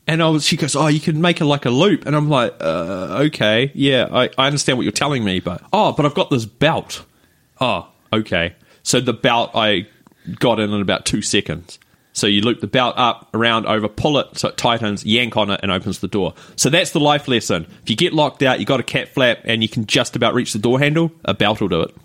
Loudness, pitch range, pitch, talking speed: -17 LUFS, 105-150 Hz, 120 Hz, 255 wpm